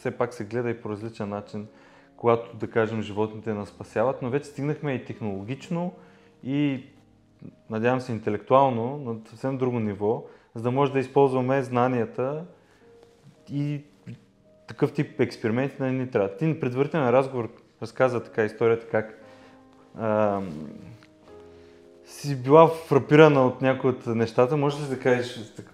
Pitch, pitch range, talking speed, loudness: 125 Hz, 110-135 Hz, 140 wpm, -25 LUFS